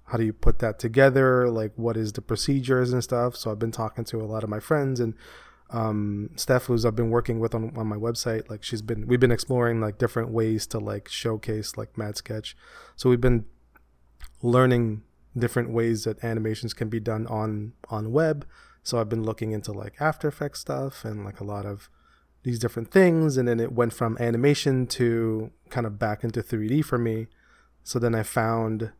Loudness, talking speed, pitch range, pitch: -26 LUFS, 205 wpm, 110-125 Hz, 115 Hz